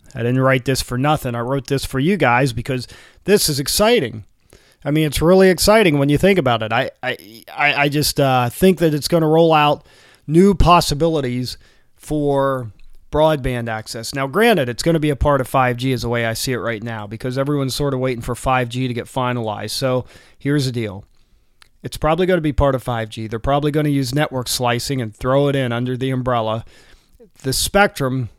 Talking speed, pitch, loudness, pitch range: 200 wpm, 130 Hz, -18 LUFS, 120-150 Hz